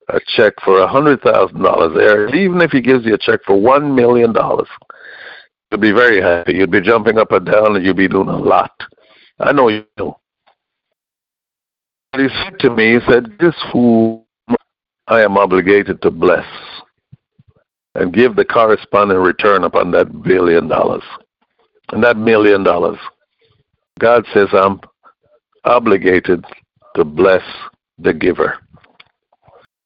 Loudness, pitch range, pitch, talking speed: -12 LUFS, 100-130 Hz, 115 Hz, 145 wpm